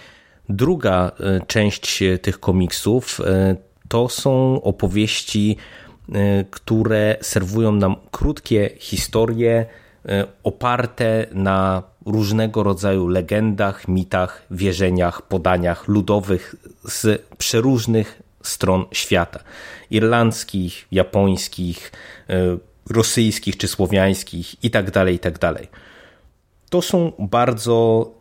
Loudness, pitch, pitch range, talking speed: -19 LUFS, 100 Hz, 95-110 Hz, 75 wpm